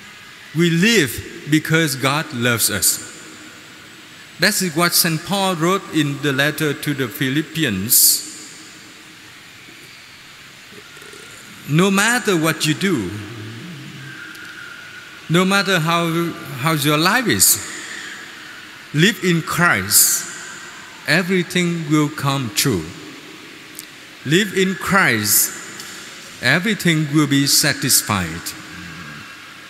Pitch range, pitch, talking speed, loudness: 140-185 Hz, 160 Hz, 85 wpm, -16 LUFS